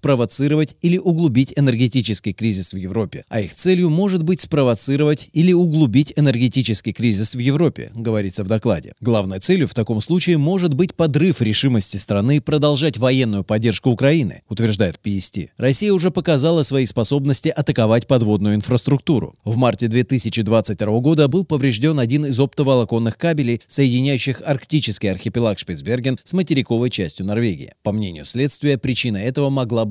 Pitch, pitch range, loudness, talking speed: 130 Hz, 110-150 Hz, -17 LUFS, 140 wpm